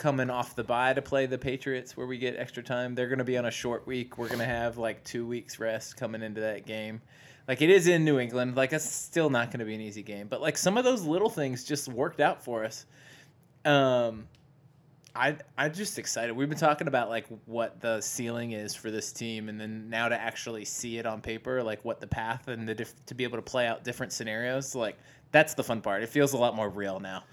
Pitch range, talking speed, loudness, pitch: 115-140 Hz, 255 wpm, -30 LUFS, 125 Hz